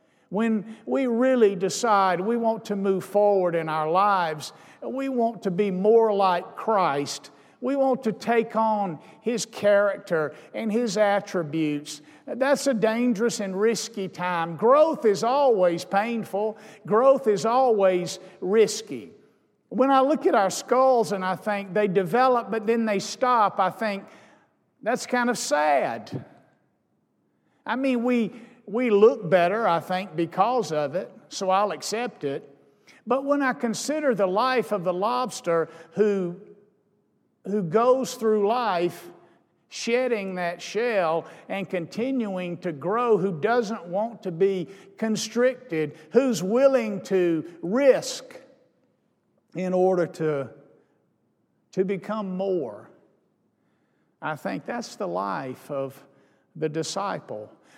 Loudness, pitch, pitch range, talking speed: -24 LUFS, 205 Hz, 185-235 Hz, 130 wpm